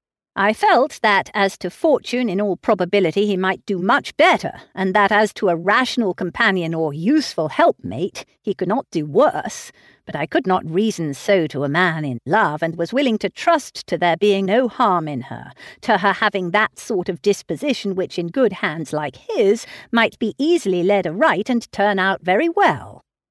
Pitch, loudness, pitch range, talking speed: 200 Hz, -19 LUFS, 180-225 Hz, 195 wpm